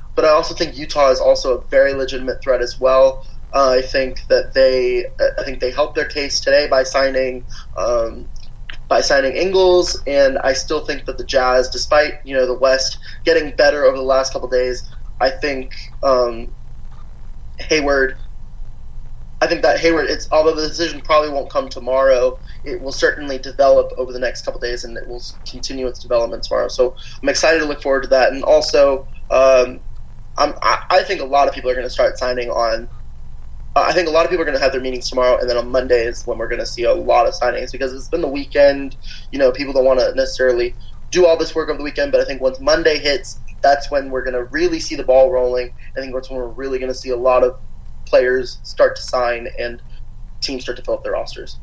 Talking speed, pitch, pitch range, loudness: 225 wpm, 130 Hz, 125-150 Hz, -17 LUFS